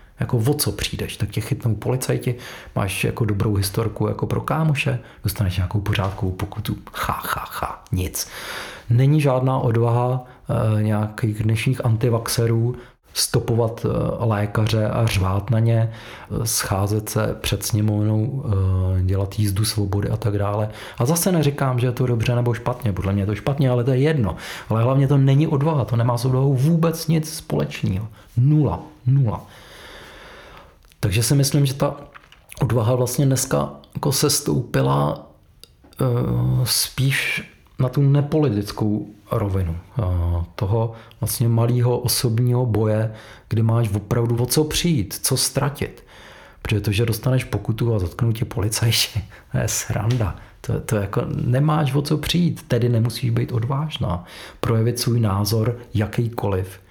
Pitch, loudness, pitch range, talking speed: 115 Hz, -21 LUFS, 105-130 Hz, 145 wpm